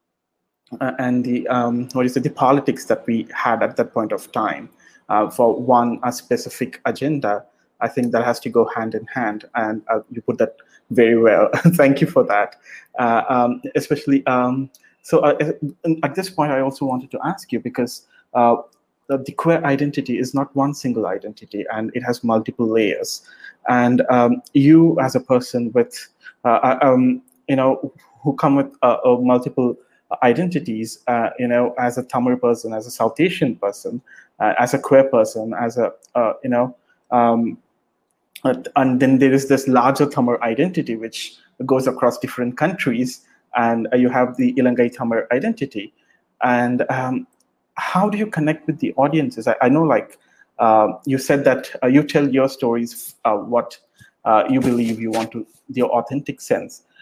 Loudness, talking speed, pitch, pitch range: -19 LUFS, 180 wpm, 125 Hz, 120-140 Hz